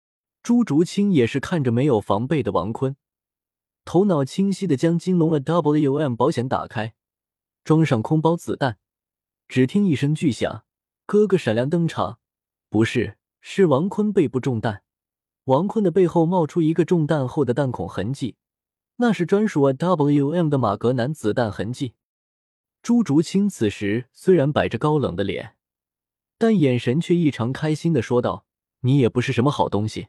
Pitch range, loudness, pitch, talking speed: 115-170 Hz, -21 LUFS, 140 Hz, 240 characters per minute